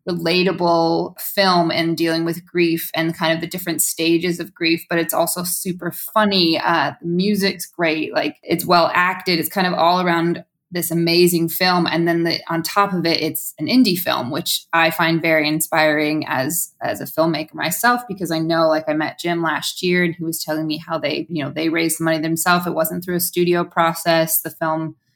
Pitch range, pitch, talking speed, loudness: 160-175 Hz, 165 Hz, 210 wpm, -18 LUFS